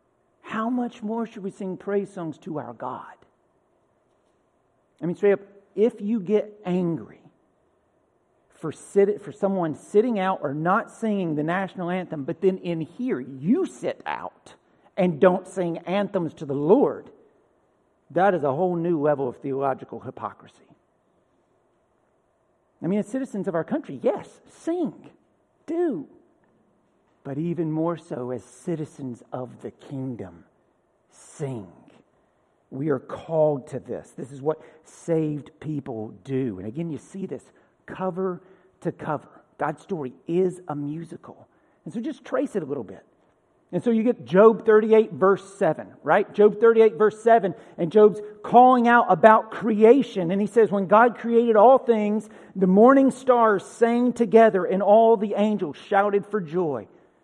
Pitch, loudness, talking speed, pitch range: 190 Hz, -22 LUFS, 150 wpm, 160-220 Hz